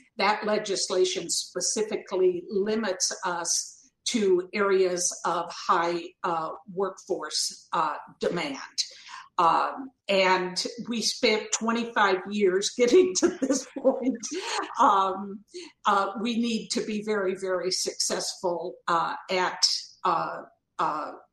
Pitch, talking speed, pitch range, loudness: 205 Hz, 100 wpm, 185-240 Hz, -26 LUFS